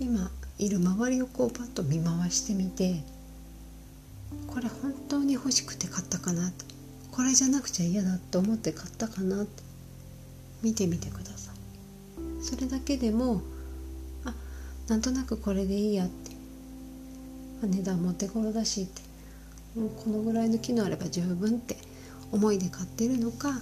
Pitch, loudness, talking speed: 195 Hz, -30 LUFS, 280 characters per minute